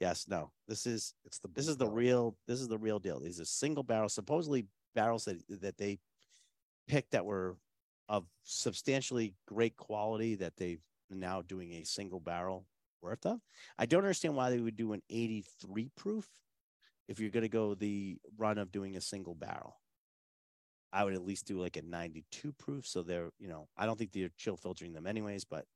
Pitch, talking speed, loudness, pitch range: 105 Hz, 200 wpm, -38 LUFS, 95-115 Hz